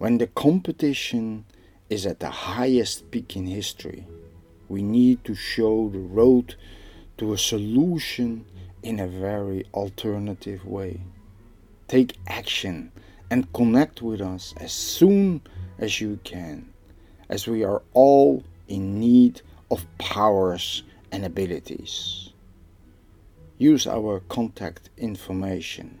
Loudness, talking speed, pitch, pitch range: -23 LUFS, 115 wpm, 100 Hz, 90-115 Hz